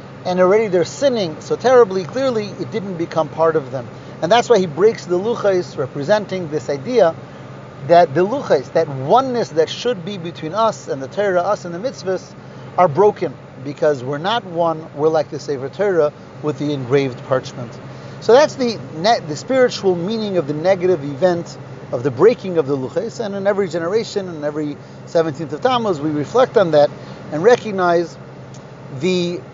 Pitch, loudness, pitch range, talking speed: 175 Hz, -18 LUFS, 150-205 Hz, 180 wpm